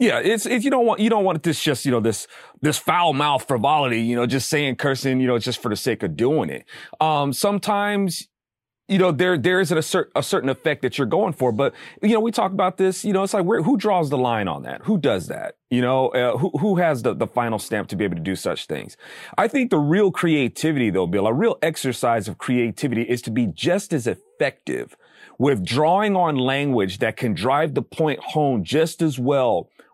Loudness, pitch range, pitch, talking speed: -21 LUFS, 130-195 Hz, 155 Hz, 235 wpm